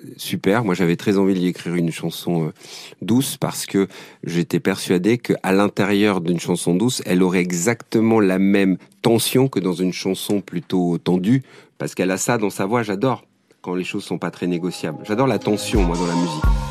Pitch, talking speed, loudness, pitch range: 95 Hz, 190 wpm, -20 LUFS, 90-105 Hz